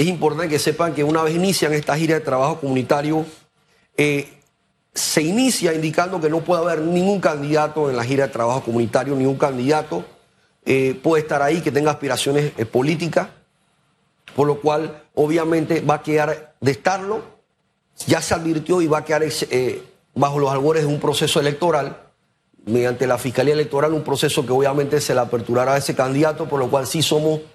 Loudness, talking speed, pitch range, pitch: -19 LUFS, 180 wpm, 140-160 Hz, 150 Hz